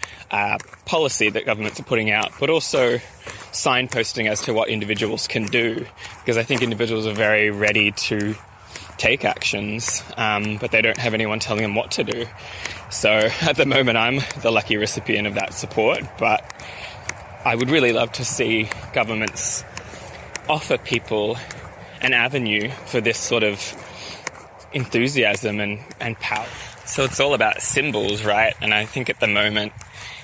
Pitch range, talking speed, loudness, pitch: 105-115 Hz, 160 wpm, -20 LUFS, 110 Hz